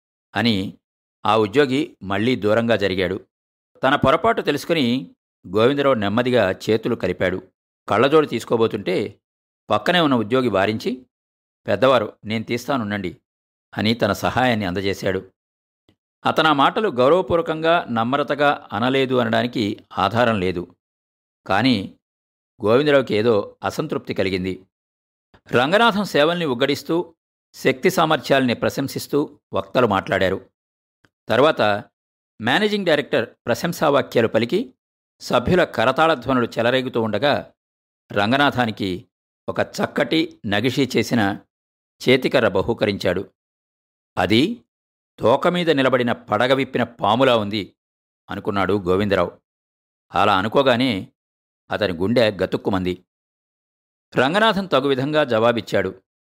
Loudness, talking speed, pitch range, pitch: -20 LUFS, 85 wpm, 90-135 Hz, 110 Hz